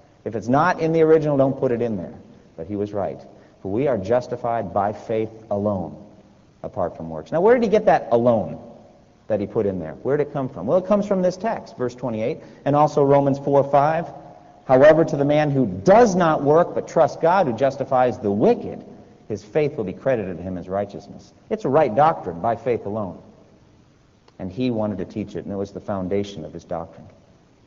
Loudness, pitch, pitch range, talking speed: -21 LUFS, 125 Hz, 100-150 Hz, 215 wpm